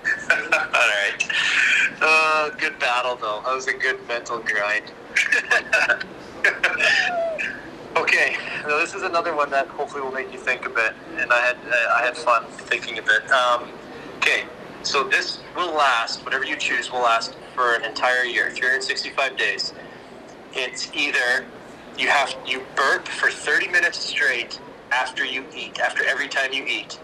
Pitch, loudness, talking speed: 145 Hz, -21 LUFS, 160 wpm